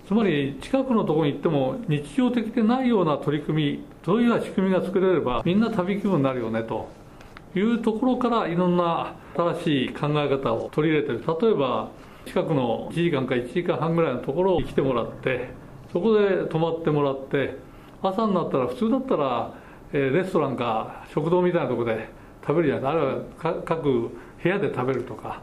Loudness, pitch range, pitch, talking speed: -24 LUFS, 140-200 Hz, 165 Hz, 390 characters per minute